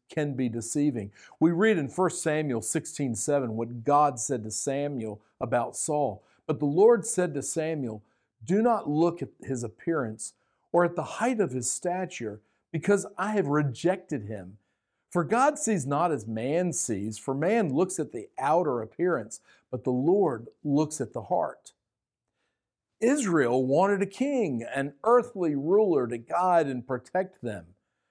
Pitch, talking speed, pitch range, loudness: 145 Hz, 155 wpm, 120-180 Hz, -27 LUFS